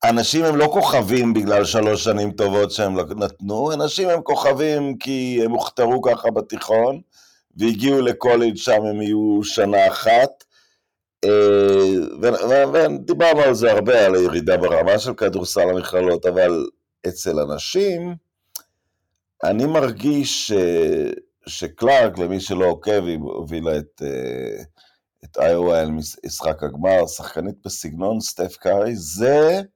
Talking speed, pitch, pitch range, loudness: 115 wpm, 110 Hz, 95-150 Hz, -18 LUFS